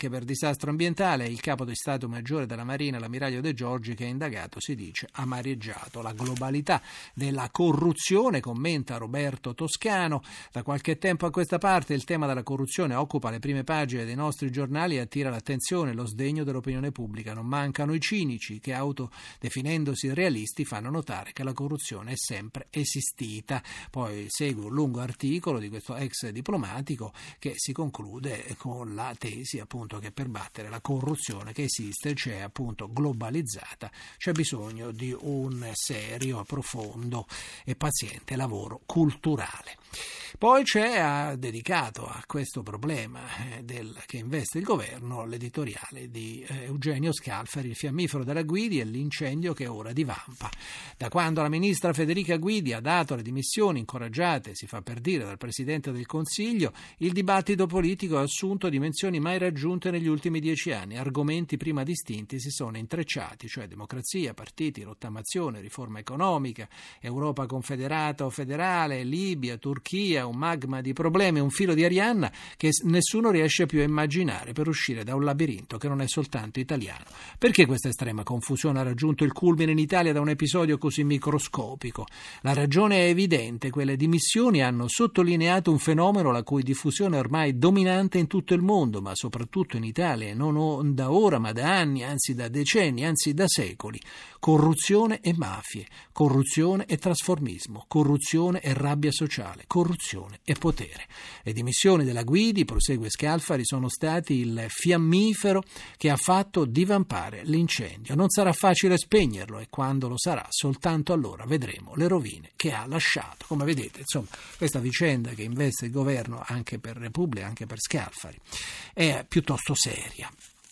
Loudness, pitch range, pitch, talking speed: -27 LUFS, 120-160 Hz, 140 Hz, 155 wpm